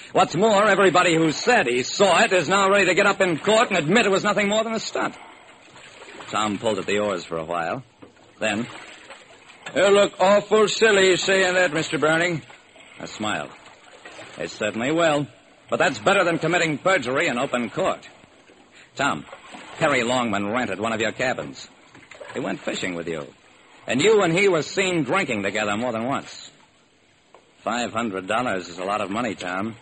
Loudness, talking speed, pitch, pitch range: -21 LUFS, 175 wpm, 170 Hz, 120-195 Hz